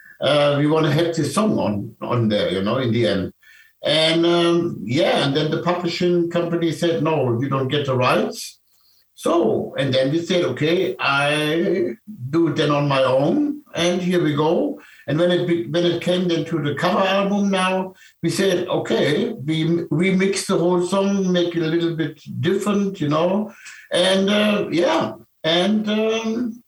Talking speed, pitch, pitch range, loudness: 180 wpm, 170 Hz, 155-185 Hz, -20 LUFS